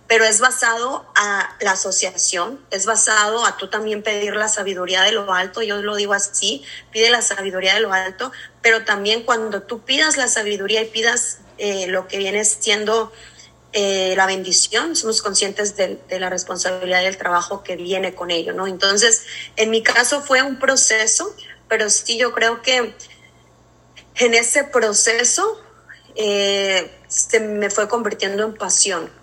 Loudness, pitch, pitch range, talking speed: -17 LUFS, 210 Hz, 190-230 Hz, 165 wpm